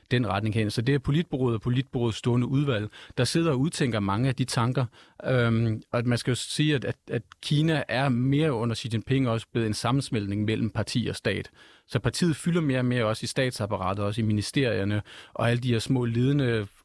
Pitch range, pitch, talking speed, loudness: 110-135 Hz, 120 Hz, 210 wpm, -27 LUFS